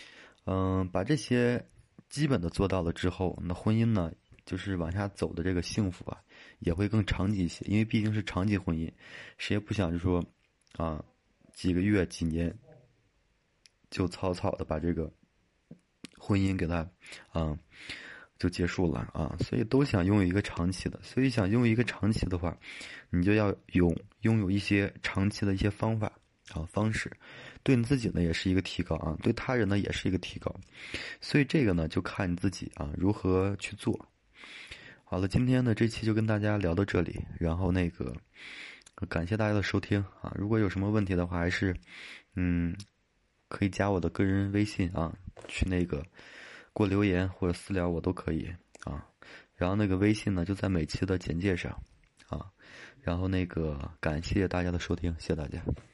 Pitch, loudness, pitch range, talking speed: 95 Hz, -31 LUFS, 85-105 Hz, 260 characters per minute